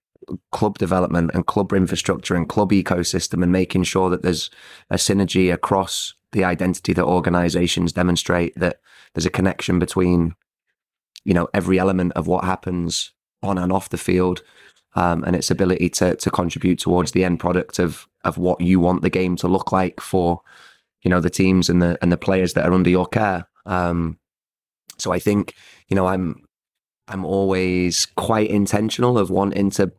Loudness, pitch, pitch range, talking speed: -20 LUFS, 90 Hz, 90-95 Hz, 175 wpm